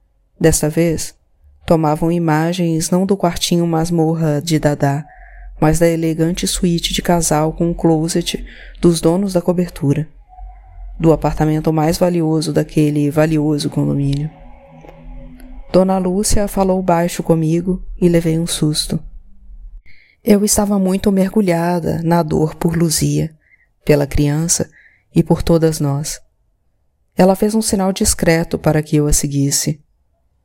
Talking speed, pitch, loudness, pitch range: 125 wpm, 160 Hz, -16 LUFS, 150-180 Hz